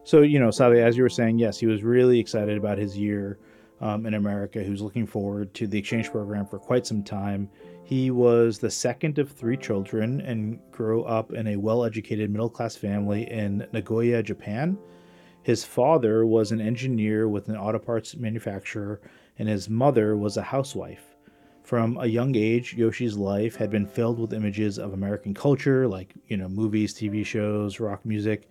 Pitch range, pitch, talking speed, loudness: 105-115 Hz, 110 Hz, 185 wpm, -25 LUFS